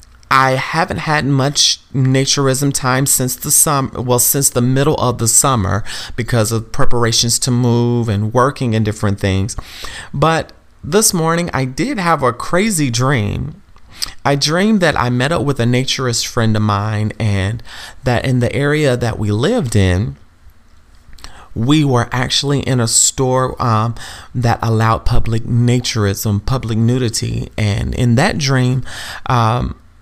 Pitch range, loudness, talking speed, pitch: 110-135 Hz, -15 LUFS, 150 wpm, 120 Hz